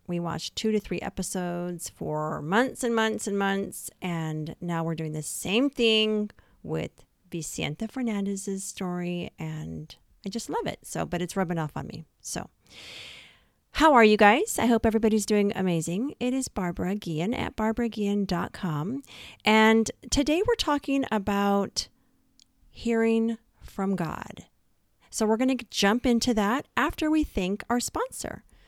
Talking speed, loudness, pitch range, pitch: 150 wpm, -27 LUFS, 175-230 Hz, 205 Hz